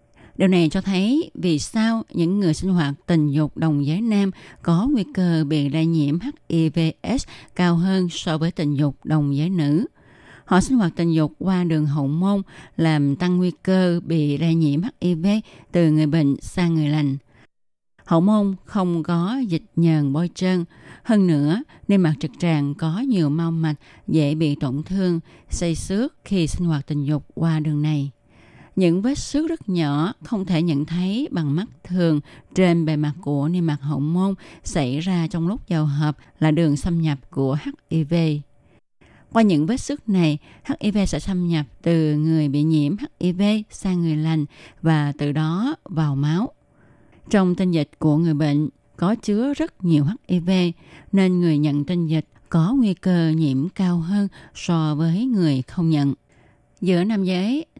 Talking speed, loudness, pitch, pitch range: 175 wpm, -21 LUFS, 165 Hz, 150-185 Hz